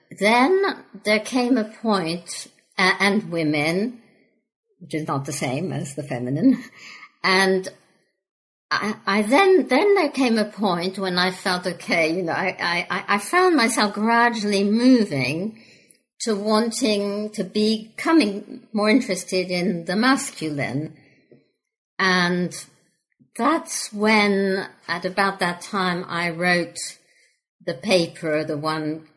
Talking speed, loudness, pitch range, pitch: 125 wpm, -21 LUFS, 175-220 Hz, 195 Hz